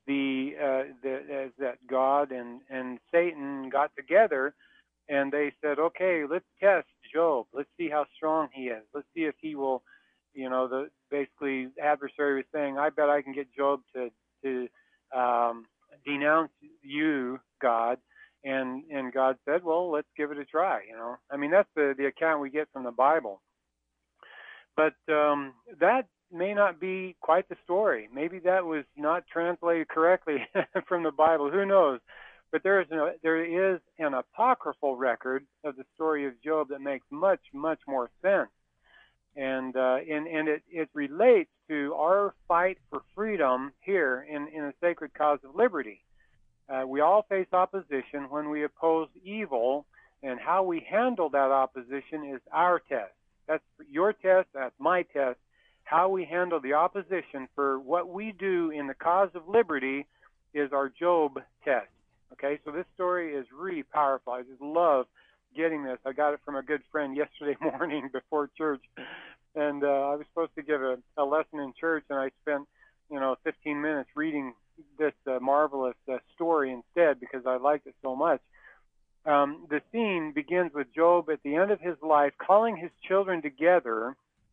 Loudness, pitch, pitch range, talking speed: -29 LUFS, 150 Hz, 135-170 Hz, 170 wpm